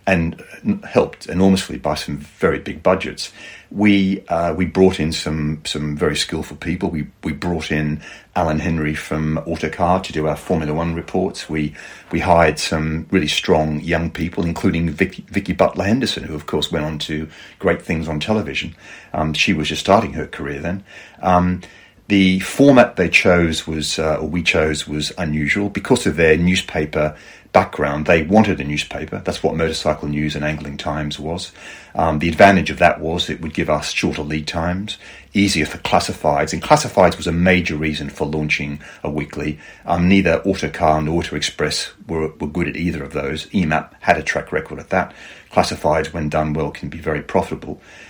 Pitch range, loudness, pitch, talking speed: 75-90 Hz, -19 LUFS, 80 Hz, 180 wpm